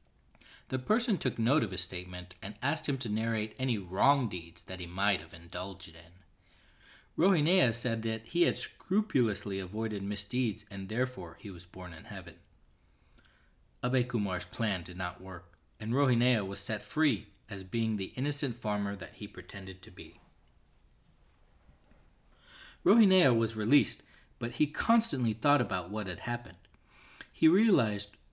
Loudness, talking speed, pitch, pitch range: -31 LUFS, 150 wpm, 105 Hz, 90-125 Hz